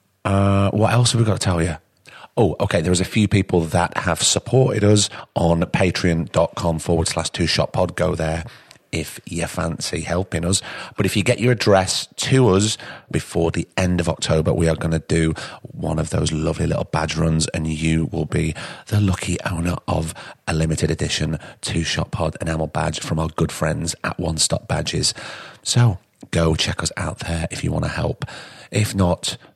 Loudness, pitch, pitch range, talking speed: -20 LUFS, 90 Hz, 80-105 Hz, 195 wpm